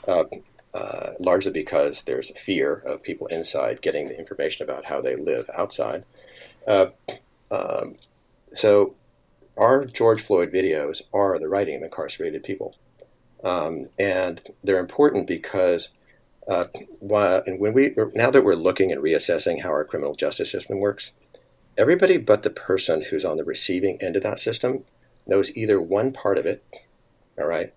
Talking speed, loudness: 160 wpm, -23 LUFS